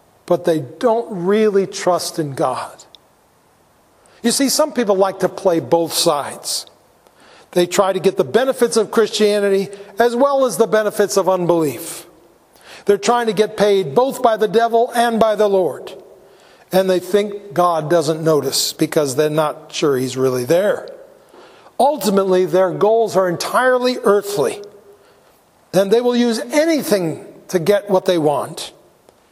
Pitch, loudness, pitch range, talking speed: 200 Hz, -17 LUFS, 175-230 Hz, 150 wpm